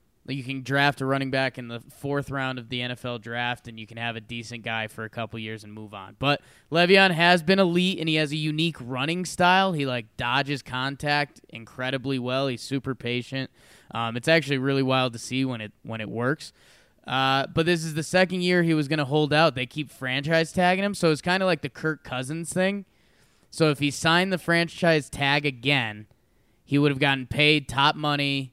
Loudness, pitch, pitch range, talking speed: -24 LUFS, 140 Hz, 125-160 Hz, 215 wpm